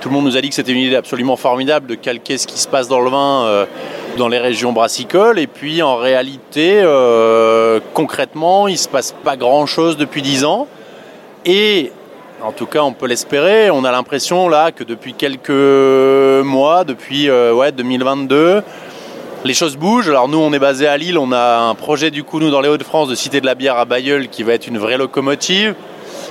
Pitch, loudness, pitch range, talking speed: 140 Hz, -13 LUFS, 125-150 Hz, 210 wpm